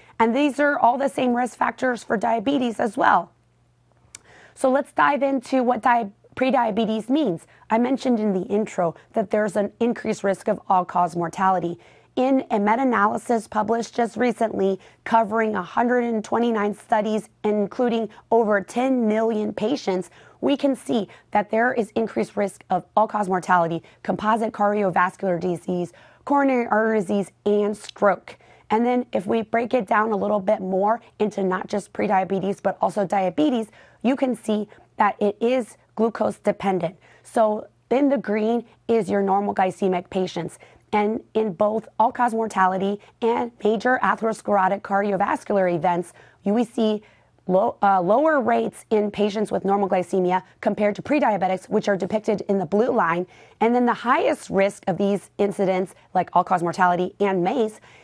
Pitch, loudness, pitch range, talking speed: 210 Hz, -22 LUFS, 195-230 Hz, 155 wpm